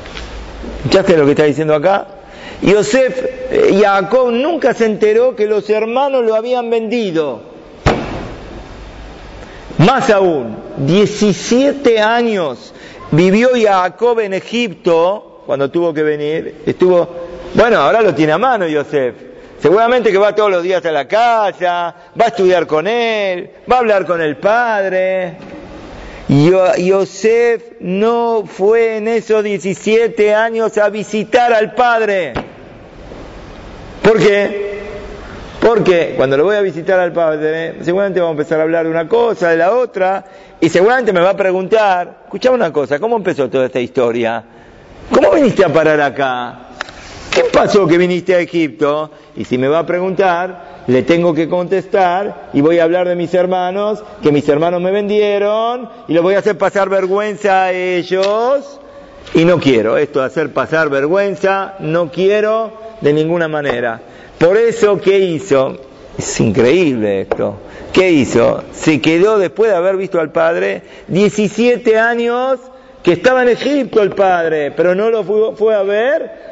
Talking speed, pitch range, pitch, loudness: 150 wpm, 170-220 Hz, 195 Hz, -13 LUFS